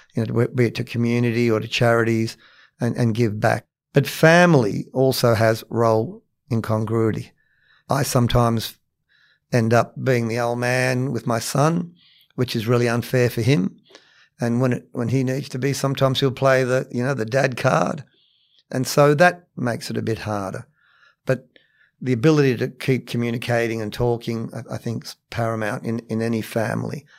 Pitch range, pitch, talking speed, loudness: 115-130 Hz, 120 Hz, 170 wpm, -21 LUFS